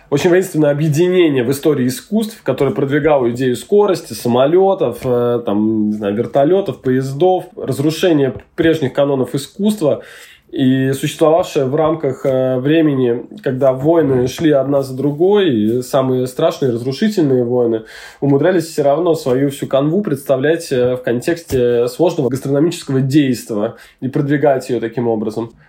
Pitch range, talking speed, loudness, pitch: 125-160 Hz, 125 wpm, -15 LUFS, 140 Hz